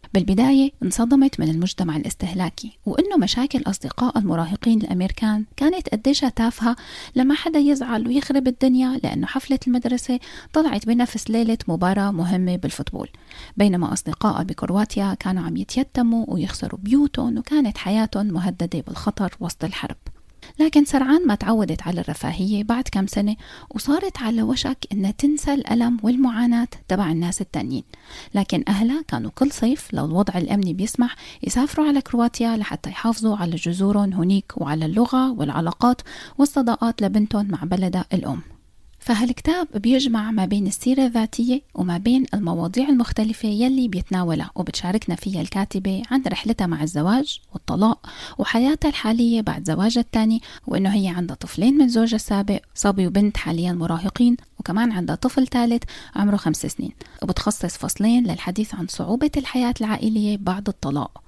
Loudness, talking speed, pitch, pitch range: -21 LUFS, 135 wpm, 220 Hz, 190-255 Hz